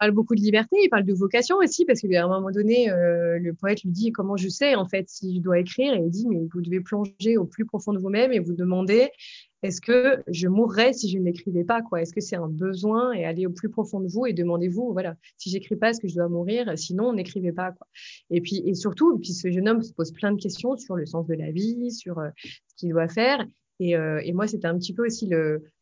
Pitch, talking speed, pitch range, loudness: 195 Hz, 265 wpm, 175-225 Hz, -24 LUFS